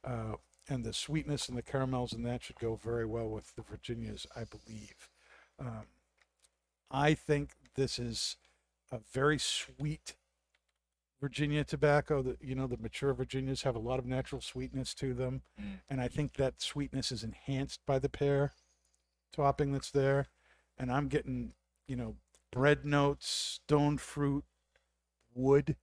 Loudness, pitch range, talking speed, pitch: -35 LUFS, 110-140 Hz, 150 wpm, 130 Hz